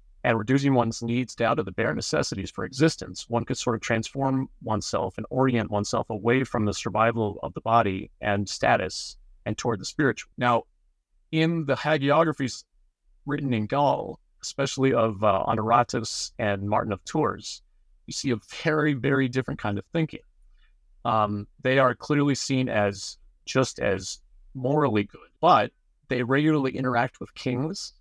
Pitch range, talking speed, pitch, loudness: 105-135 Hz, 155 wpm, 120 Hz, -26 LUFS